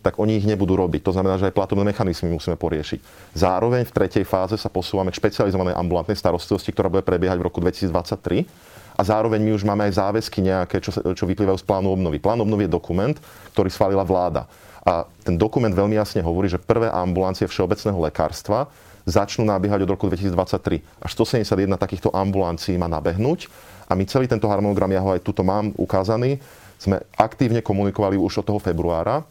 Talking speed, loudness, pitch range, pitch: 180 wpm, -21 LUFS, 90-105 Hz, 95 Hz